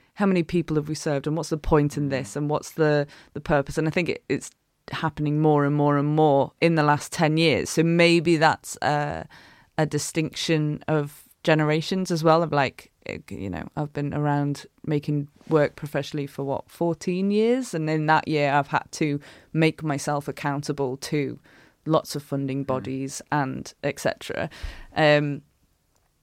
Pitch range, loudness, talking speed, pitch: 145-160 Hz, -24 LUFS, 170 wpm, 150 Hz